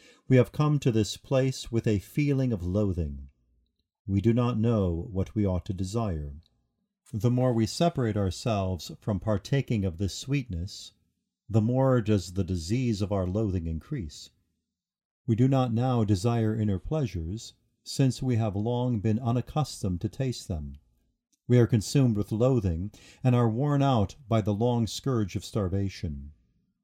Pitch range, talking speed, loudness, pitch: 95-125 Hz, 155 wpm, -28 LUFS, 110 Hz